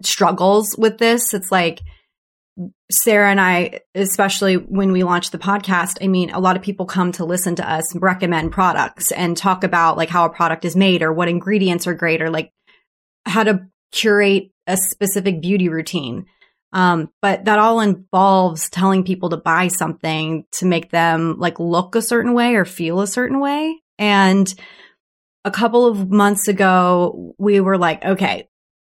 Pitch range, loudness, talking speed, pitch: 175-200 Hz, -17 LUFS, 175 wpm, 185 Hz